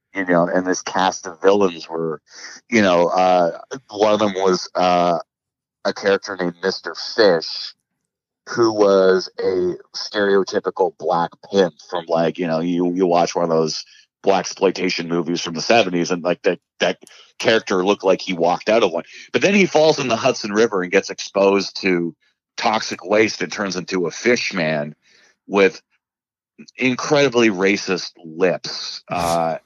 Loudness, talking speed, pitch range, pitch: -19 LUFS, 160 wpm, 85-105 Hz, 90 Hz